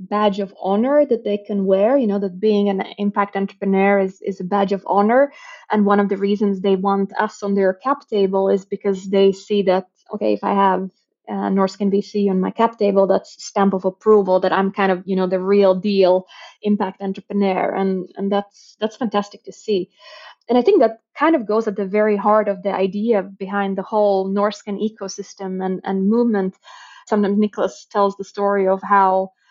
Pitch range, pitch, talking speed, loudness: 195-210 Hz, 200 Hz, 200 wpm, -19 LUFS